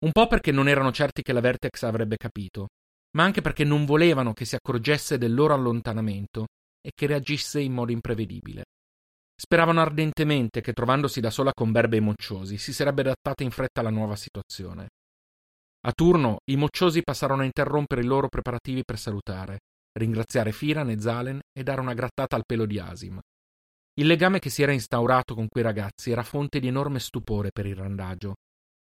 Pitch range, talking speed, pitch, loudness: 105-145 Hz, 180 wpm, 125 Hz, -25 LUFS